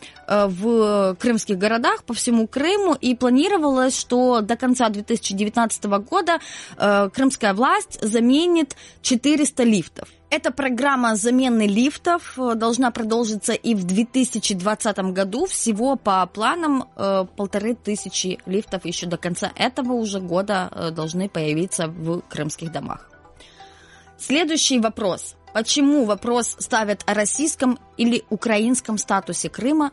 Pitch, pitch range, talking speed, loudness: 230 Hz, 200-260 Hz, 115 wpm, -21 LUFS